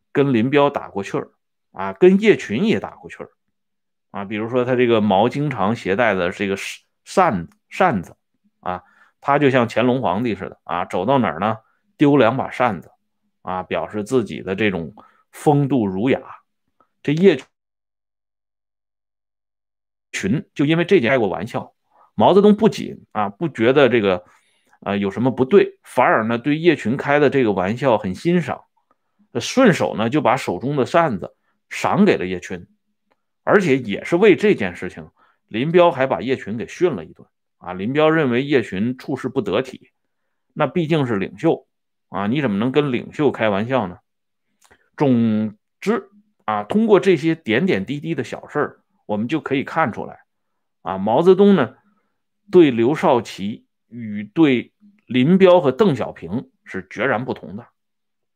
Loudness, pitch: -19 LUFS, 140 Hz